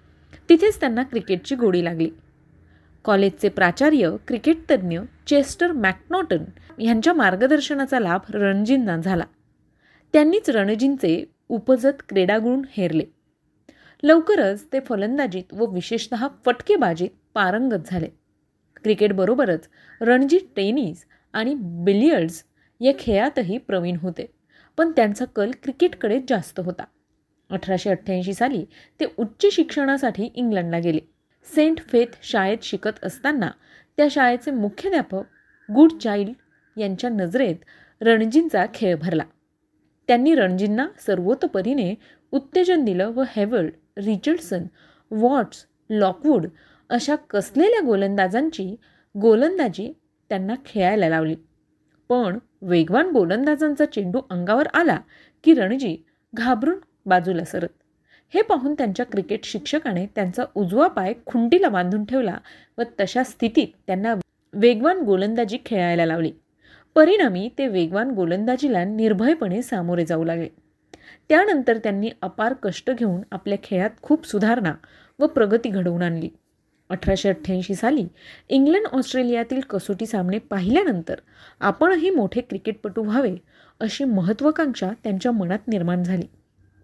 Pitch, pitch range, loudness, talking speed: 225 Hz, 190-275 Hz, -21 LUFS, 105 wpm